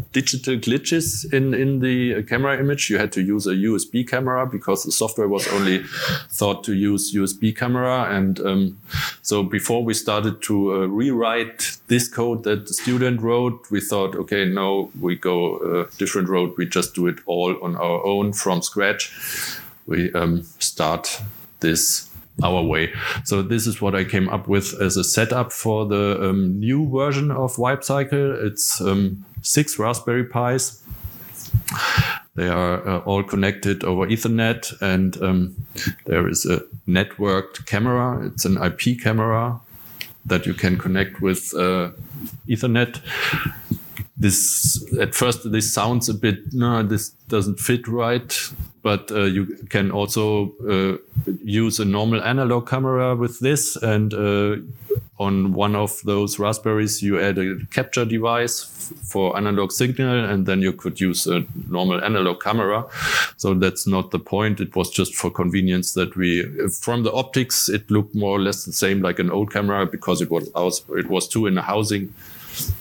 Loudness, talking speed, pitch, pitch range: -21 LUFS, 165 wpm, 105 Hz, 95-120 Hz